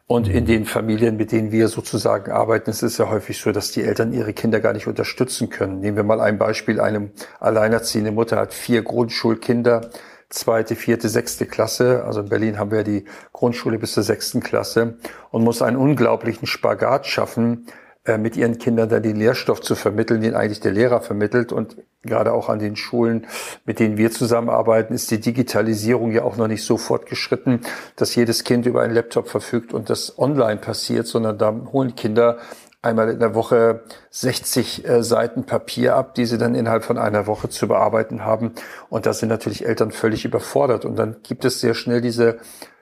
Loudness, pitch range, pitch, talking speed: -20 LUFS, 110-120 Hz, 115 Hz, 190 wpm